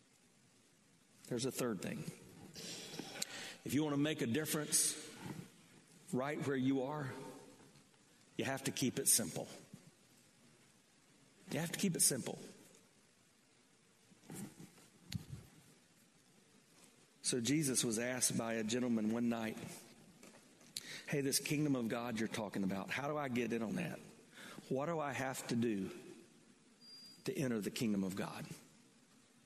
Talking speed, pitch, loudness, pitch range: 130 wpm, 130 Hz, -39 LUFS, 115-145 Hz